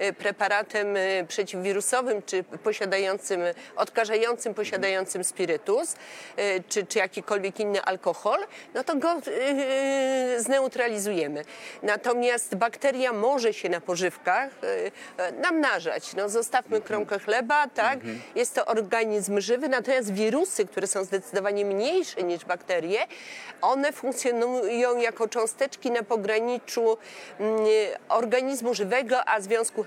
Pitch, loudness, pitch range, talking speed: 220 Hz, -26 LUFS, 200-250 Hz, 100 wpm